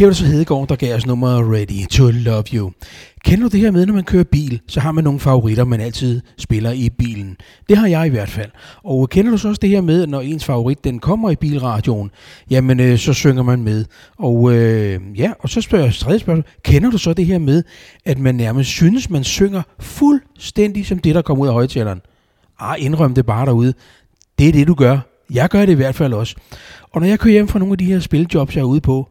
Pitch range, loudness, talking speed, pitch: 120-170 Hz, -15 LUFS, 245 wpm, 135 Hz